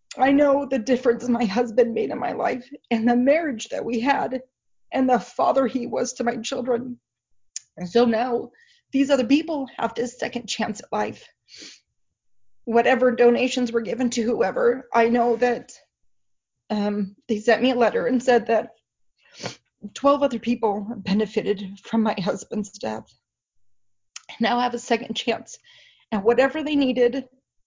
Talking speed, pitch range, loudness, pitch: 155 wpm, 220-255 Hz, -22 LUFS, 240 Hz